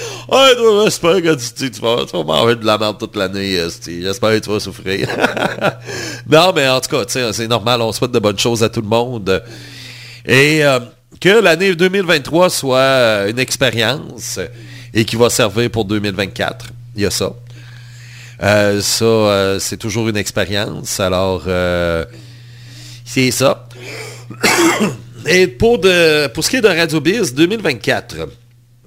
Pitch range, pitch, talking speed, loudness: 105-130 Hz, 120 Hz, 160 wpm, -14 LUFS